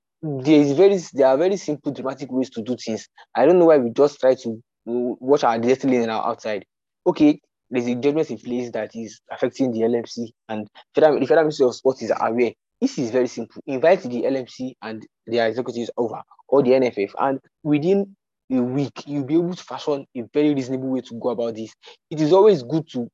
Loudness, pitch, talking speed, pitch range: -21 LUFS, 130 Hz, 210 wpm, 120-150 Hz